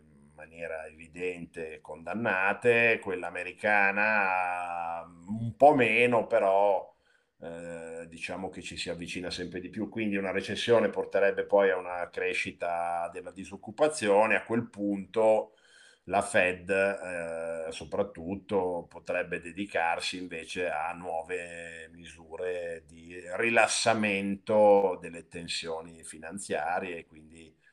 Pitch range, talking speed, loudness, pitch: 85-100 Hz, 105 wpm, -29 LUFS, 90 Hz